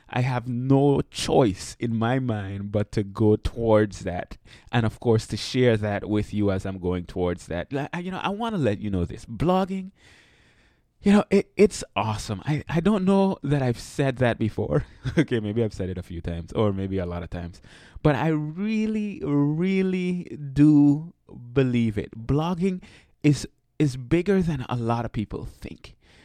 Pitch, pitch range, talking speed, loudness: 120 Hz, 105-150 Hz, 185 wpm, -24 LUFS